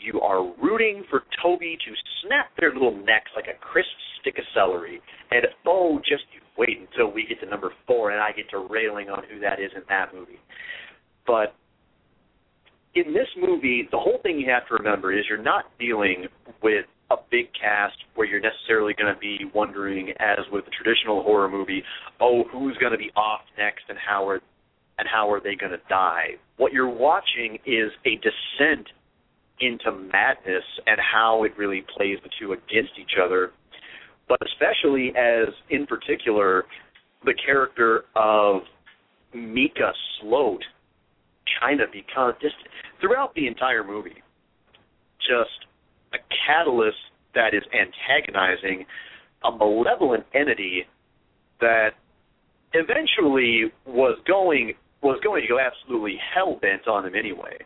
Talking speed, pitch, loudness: 150 wpm, 120 Hz, -23 LUFS